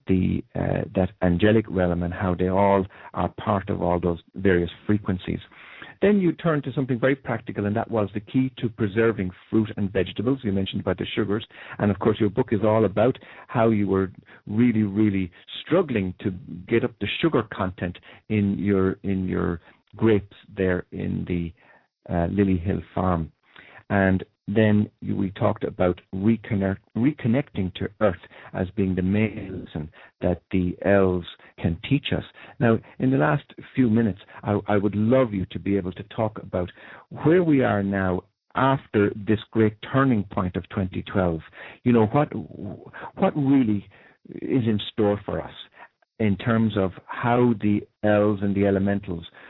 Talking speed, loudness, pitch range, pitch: 165 wpm, -24 LUFS, 95-115 Hz, 105 Hz